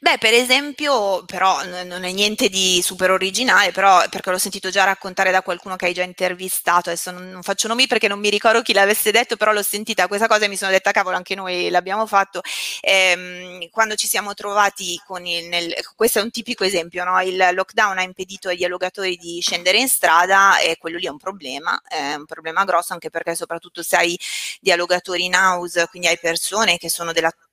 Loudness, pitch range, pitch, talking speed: -18 LUFS, 175-205 Hz, 185 Hz, 210 wpm